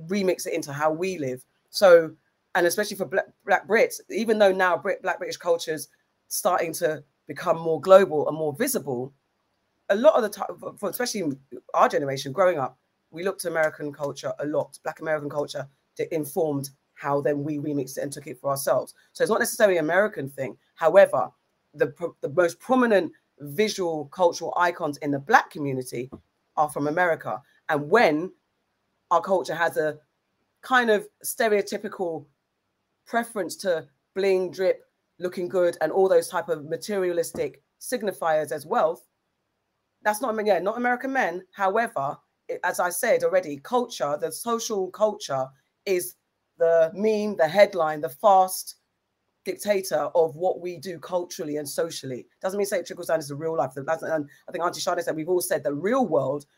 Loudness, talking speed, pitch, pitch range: -25 LUFS, 175 wpm, 175 Hz, 150-200 Hz